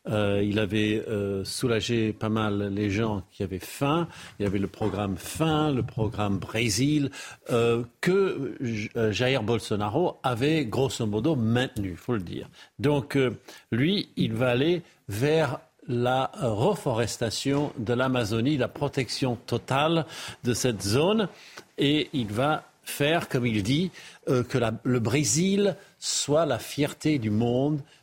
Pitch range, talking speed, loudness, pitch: 110-145 Hz, 145 wpm, -27 LUFS, 125 Hz